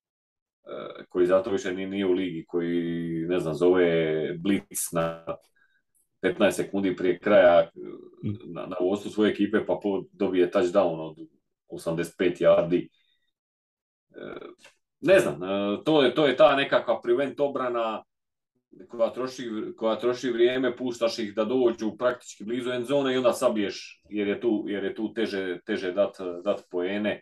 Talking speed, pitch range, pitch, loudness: 135 wpm, 90-125 Hz, 105 Hz, -26 LUFS